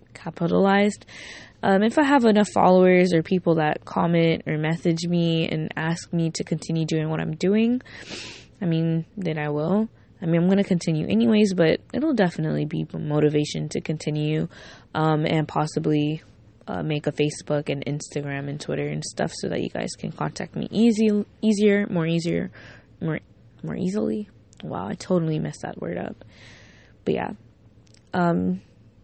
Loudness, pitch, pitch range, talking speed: -23 LUFS, 160 Hz, 150-185 Hz, 165 wpm